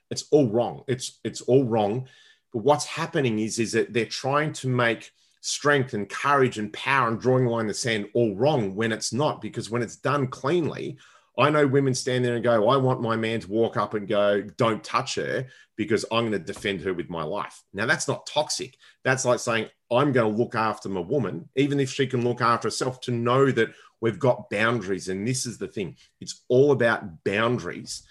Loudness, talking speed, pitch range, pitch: -25 LUFS, 215 wpm, 110-130 Hz, 120 Hz